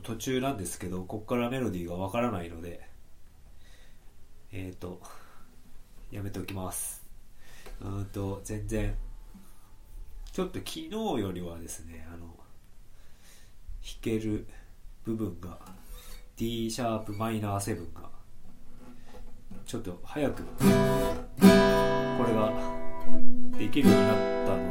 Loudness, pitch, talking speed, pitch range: -30 LUFS, 95 Hz, 220 characters per minute, 80-110 Hz